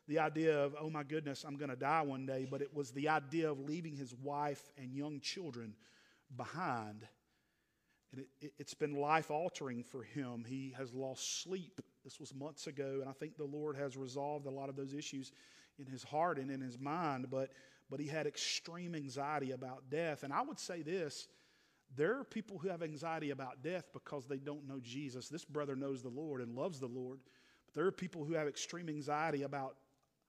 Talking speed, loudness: 205 wpm, -42 LUFS